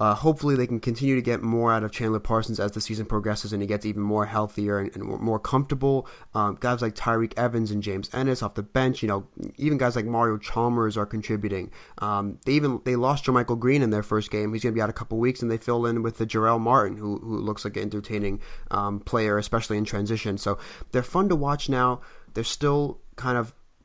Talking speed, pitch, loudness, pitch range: 240 wpm, 115 Hz, -26 LUFS, 105-125 Hz